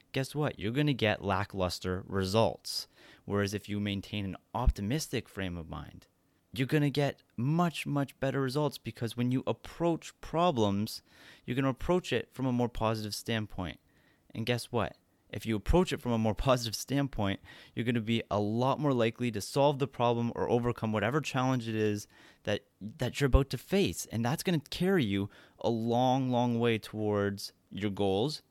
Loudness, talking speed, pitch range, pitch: -32 LUFS, 175 wpm, 105-135 Hz, 115 Hz